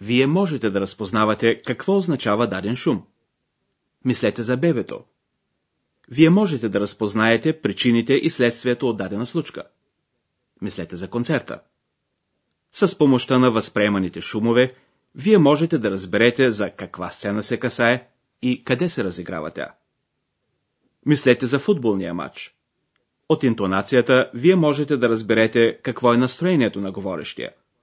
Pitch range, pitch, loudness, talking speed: 105-135 Hz, 120 Hz, -20 LUFS, 125 wpm